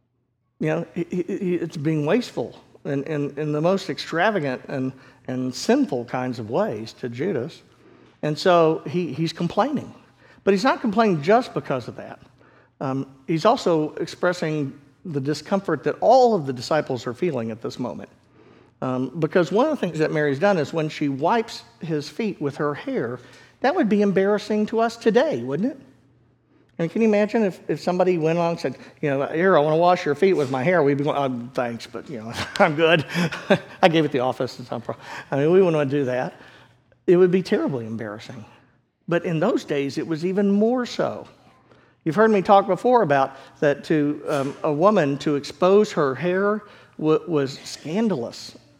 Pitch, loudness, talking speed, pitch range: 155 Hz, -22 LUFS, 195 wpm, 135-190 Hz